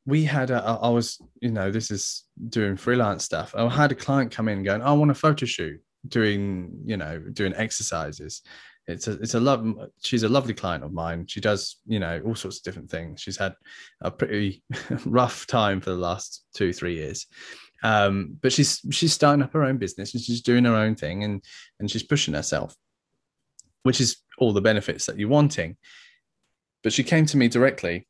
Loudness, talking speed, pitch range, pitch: -24 LUFS, 205 wpm, 100-130 Hz, 115 Hz